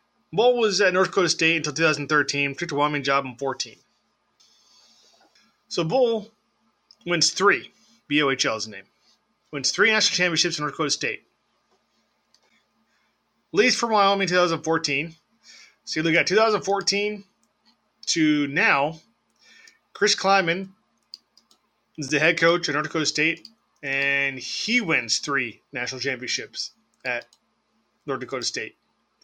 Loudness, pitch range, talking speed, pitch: -22 LUFS, 140-200 Hz, 125 wpm, 165 Hz